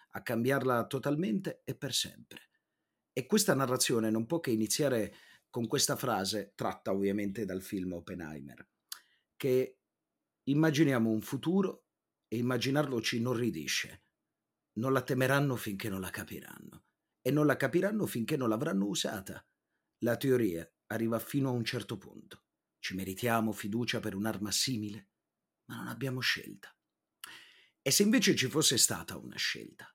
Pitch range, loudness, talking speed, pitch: 105-135 Hz, -32 LUFS, 140 wpm, 120 Hz